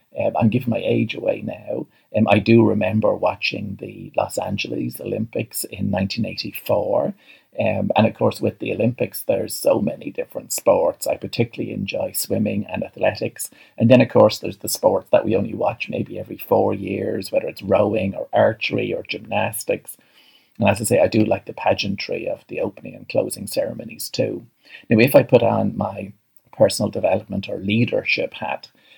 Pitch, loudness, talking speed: 115 Hz, -21 LUFS, 175 wpm